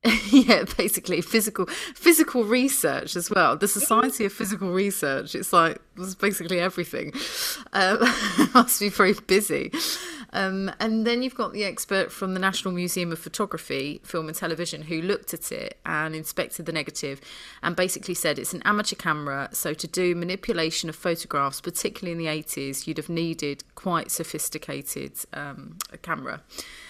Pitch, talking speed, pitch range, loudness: 180 Hz, 160 wpm, 160-205 Hz, -24 LUFS